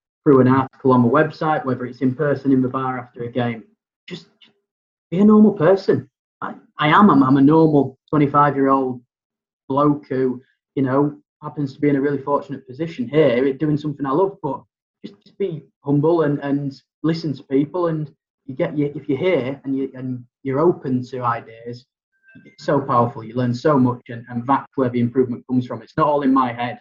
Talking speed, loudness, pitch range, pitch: 210 wpm, -19 LUFS, 130-150 Hz, 140 Hz